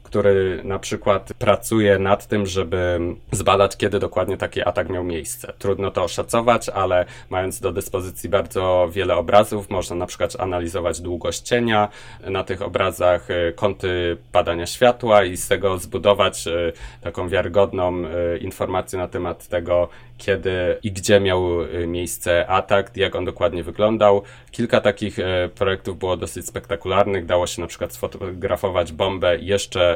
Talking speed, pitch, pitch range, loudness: 140 wpm, 95 Hz, 90-105 Hz, -21 LUFS